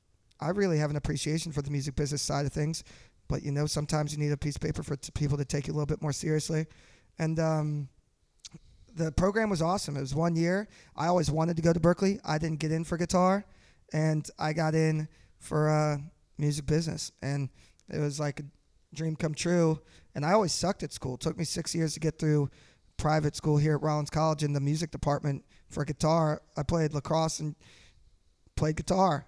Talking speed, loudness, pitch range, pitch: 215 wpm, -30 LUFS, 145-160 Hz, 155 Hz